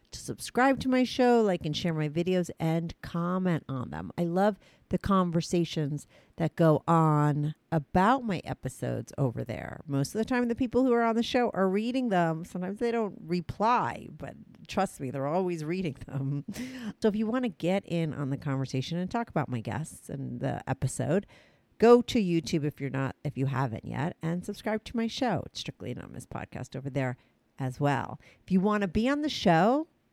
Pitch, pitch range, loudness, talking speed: 170 Hz, 140-215 Hz, -29 LUFS, 200 wpm